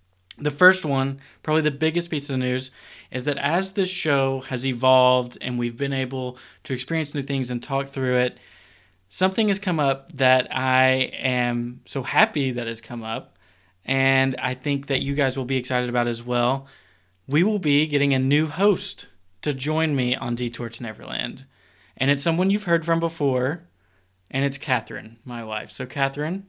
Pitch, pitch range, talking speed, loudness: 130 Hz, 120-145 Hz, 185 wpm, -23 LUFS